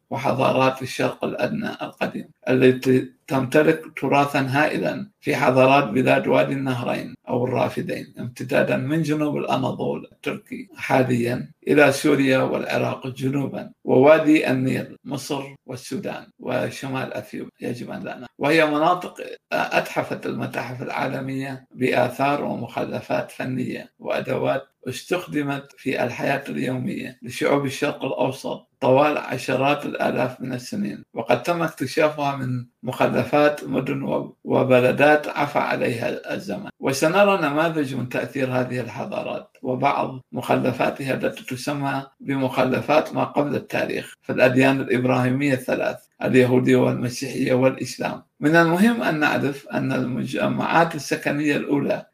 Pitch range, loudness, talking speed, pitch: 130-150 Hz, -22 LUFS, 110 wpm, 135 Hz